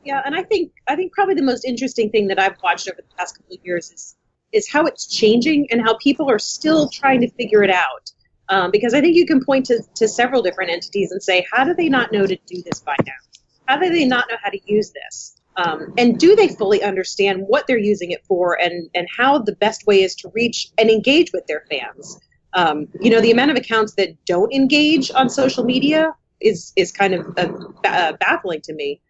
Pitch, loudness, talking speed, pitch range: 230 Hz, -17 LUFS, 235 wpm, 195-275 Hz